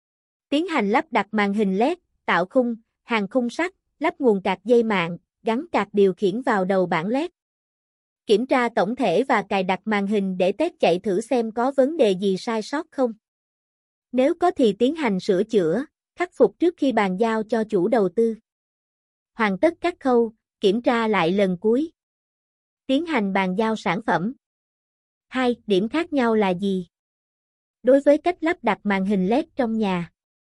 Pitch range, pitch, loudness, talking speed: 200-265 Hz, 225 Hz, -22 LUFS, 185 wpm